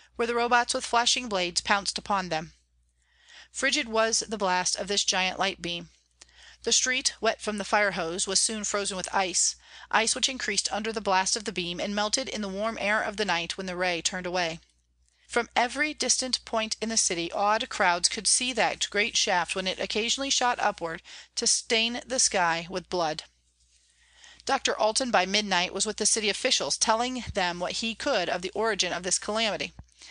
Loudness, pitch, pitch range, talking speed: -26 LUFS, 205 Hz, 180-225 Hz, 195 wpm